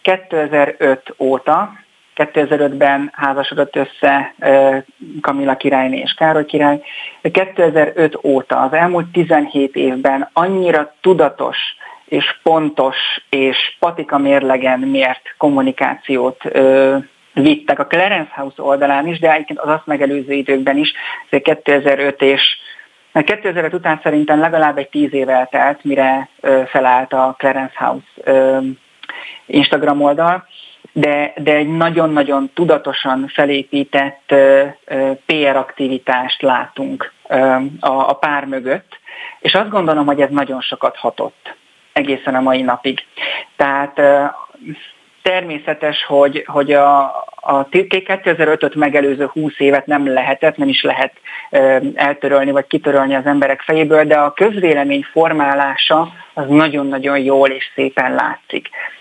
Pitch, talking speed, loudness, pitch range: 140 Hz, 125 wpm, -14 LUFS, 135-155 Hz